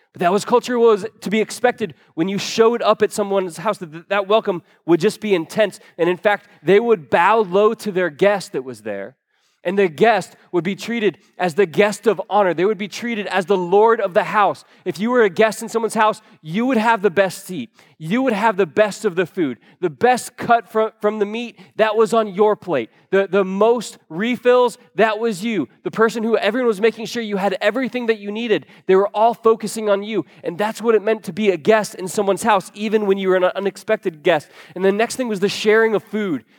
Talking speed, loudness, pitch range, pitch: 235 wpm, -18 LUFS, 195-225 Hz, 210 Hz